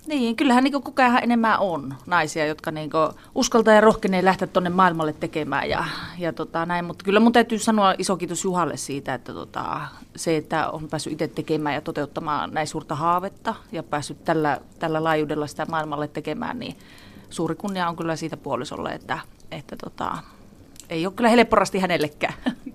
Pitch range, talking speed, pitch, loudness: 155-200 Hz, 170 wpm, 165 Hz, -23 LUFS